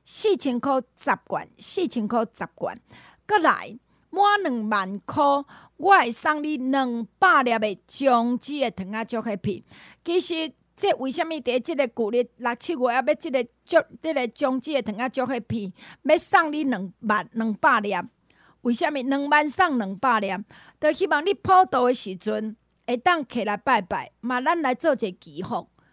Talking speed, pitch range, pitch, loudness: 235 characters per minute, 225-310 Hz, 260 Hz, -24 LUFS